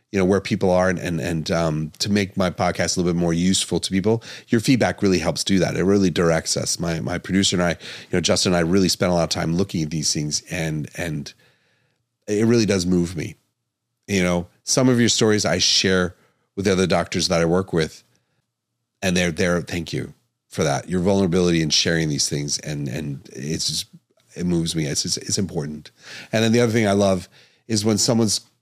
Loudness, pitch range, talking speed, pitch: -20 LUFS, 85-105 Hz, 225 wpm, 90 Hz